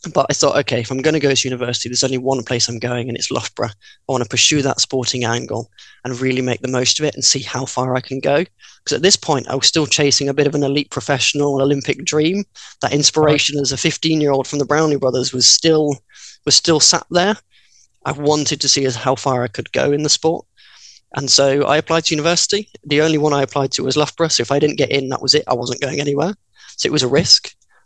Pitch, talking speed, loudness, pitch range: 140 Hz, 255 wpm, -16 LUFS, 130-150 Hz